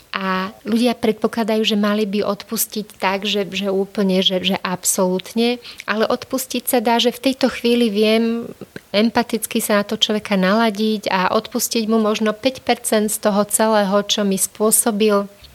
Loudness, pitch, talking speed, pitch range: -18 LUFS, 220 Hz, 155 wpm, 205-235 Hz